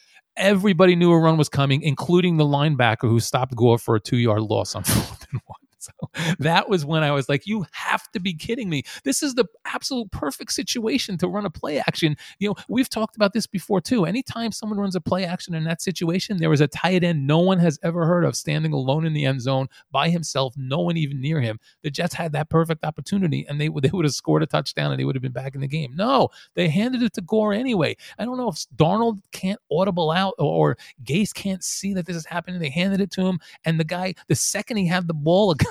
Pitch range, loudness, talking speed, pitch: 145-195 Hz, -22 LUFS, 250 wpm, 170 Hz